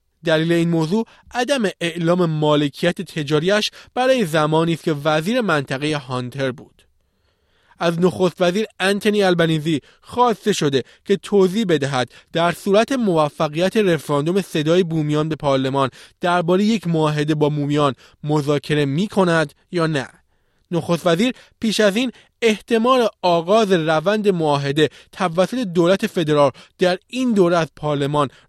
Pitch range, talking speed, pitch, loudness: 150-195 Hz, 125 wpm, 170 Hz, -19 LUFS